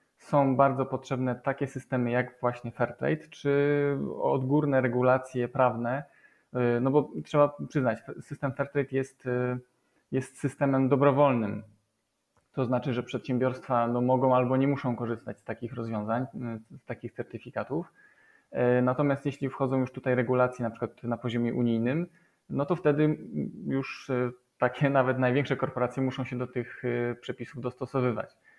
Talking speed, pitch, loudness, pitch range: 130 wpm, 130 Hz, -29 LUFS, 120-140 Hz